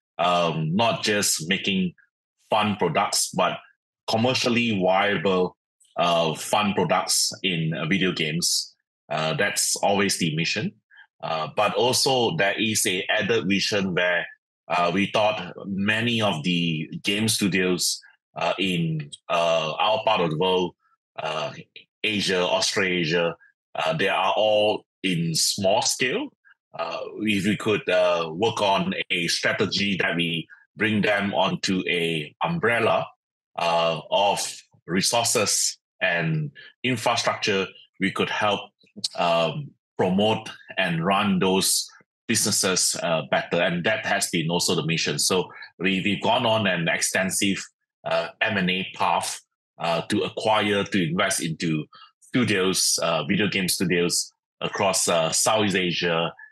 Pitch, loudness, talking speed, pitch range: 95 Hz, -23 LUFS, 125 wpm, 85-105 Hz